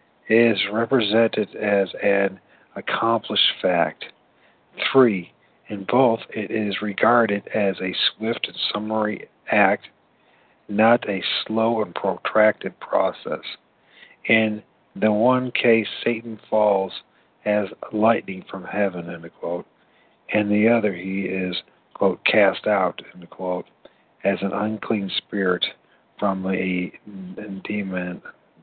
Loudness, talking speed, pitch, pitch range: -22 LUFS, 110 wpm, 105 Hz, 95-110 Hz